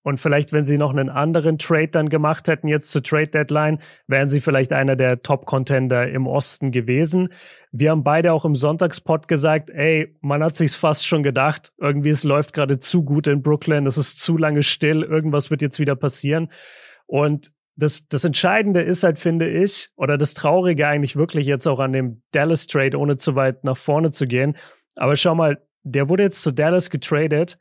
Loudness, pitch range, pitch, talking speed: -19 LUFS, 140-160 Hz, 150 Hz, 200 wpm